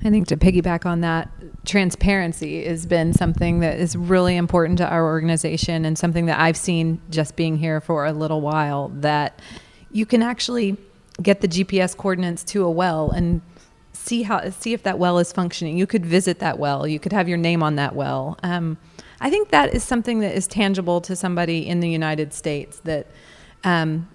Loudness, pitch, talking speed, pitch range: -21 LUFS, 170 Hz, 195 wpm, 160-190 Hz